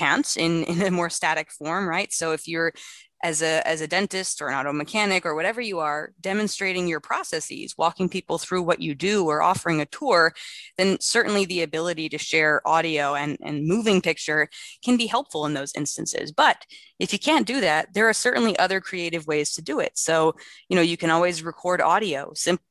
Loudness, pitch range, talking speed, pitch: -23 LUFS, 160-190 Hz, 205 wpm, 170 Hz